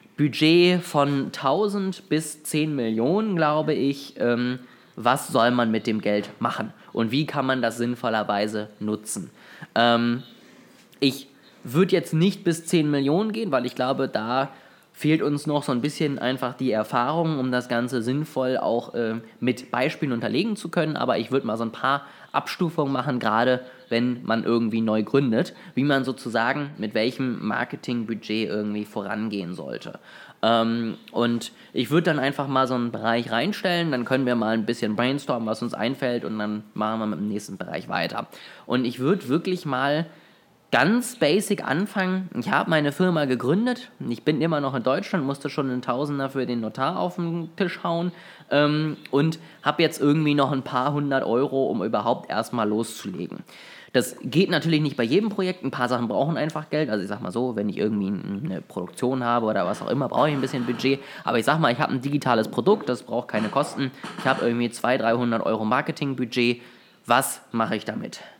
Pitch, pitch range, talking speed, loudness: 135 Hz, 120-155 Hz, 180 wpm, -24 LUFS